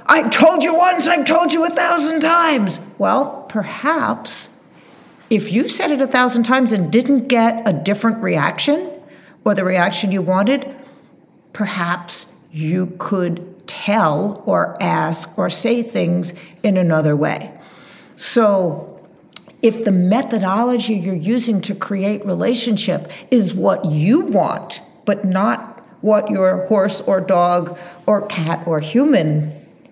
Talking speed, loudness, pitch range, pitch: 130 wpm, -17 LUFS, 185-250 Hz, 210 Hz